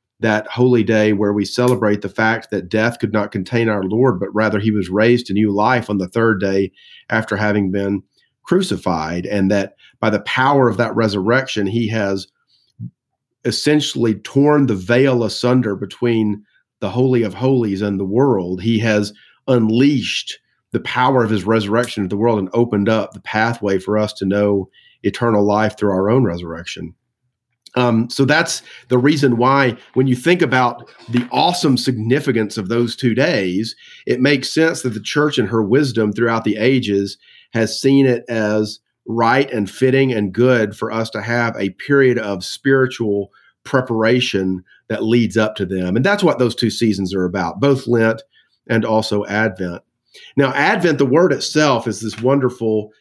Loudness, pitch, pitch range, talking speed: -17 LUFS, 115 Hz, 105-125 Hz, 175 wpm